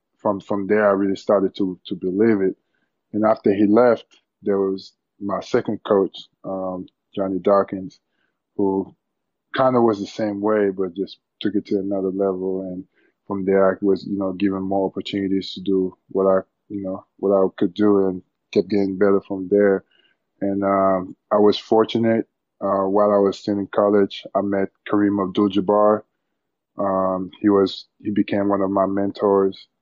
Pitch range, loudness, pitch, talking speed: 95-105 Hz, -21 LUFS, 100 Hz, 175 wpm